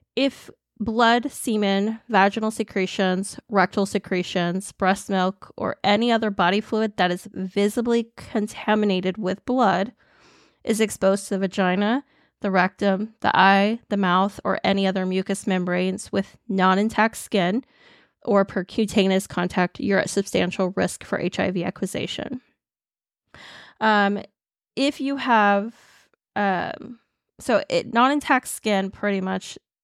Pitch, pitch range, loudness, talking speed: 200 Hz, 190-225 Hz, -22 LUFS, 125 wpm